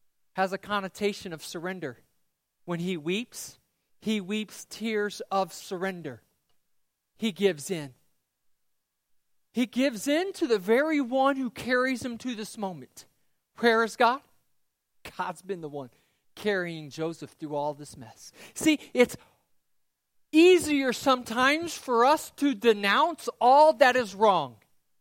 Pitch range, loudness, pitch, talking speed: 175-255 Hz, -26 LUFS, 210 Hz, 130 wpm